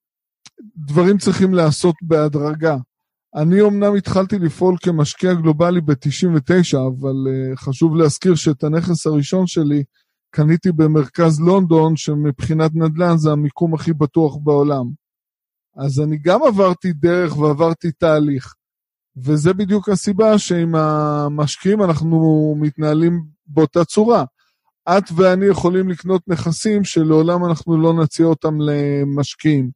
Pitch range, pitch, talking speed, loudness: 150-180 Hz, 160 Hz, 110 wpm, -16 LUFS